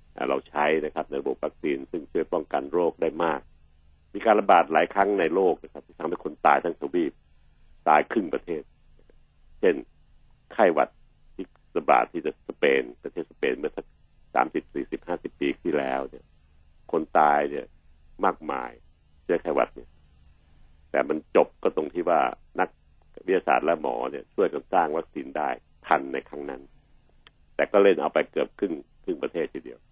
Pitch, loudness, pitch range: 75 Hz, -26 LUFS, 70-75 Hz